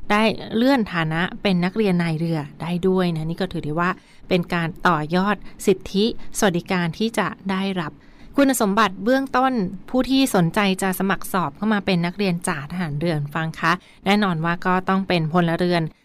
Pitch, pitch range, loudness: 185 Hz, 170-210 Hz, -21 LUFS